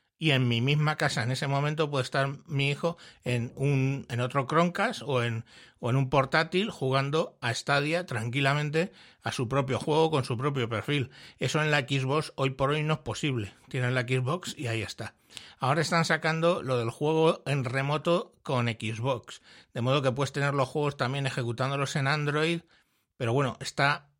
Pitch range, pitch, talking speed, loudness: 130-155 Hz, 140 Hz, 185 wpm, -28 LUFS